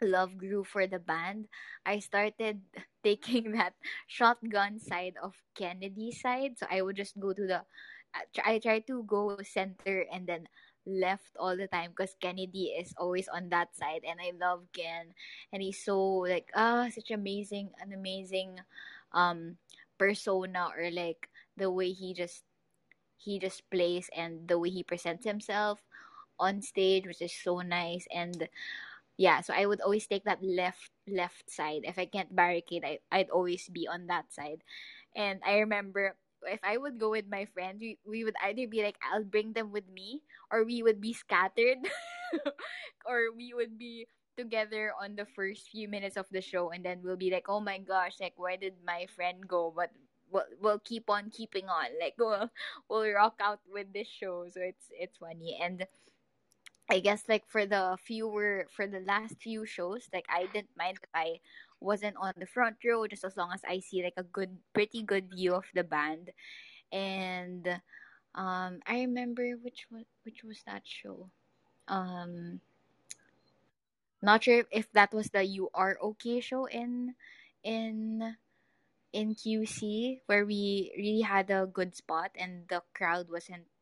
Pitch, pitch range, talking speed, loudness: 195 Hz, 180-215 Hz, 175 wpm, -33 LUFS